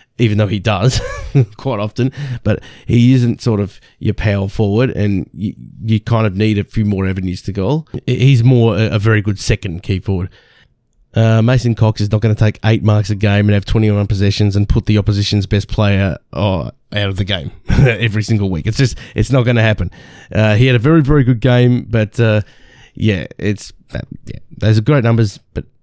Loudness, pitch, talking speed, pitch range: -15 LUFS, 110 Hz, 210 wpm, 105-120 Hz